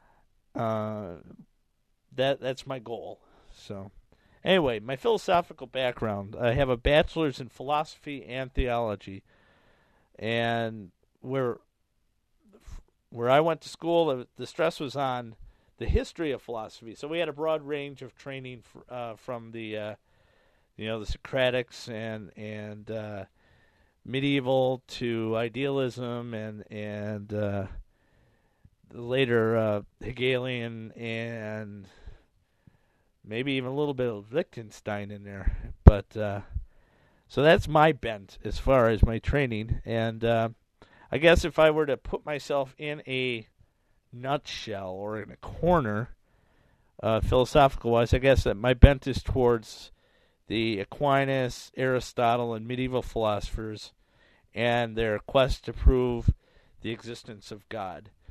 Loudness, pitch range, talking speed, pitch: -28 LUFS, 105-130 Hz, 130 wpm, 115 Hz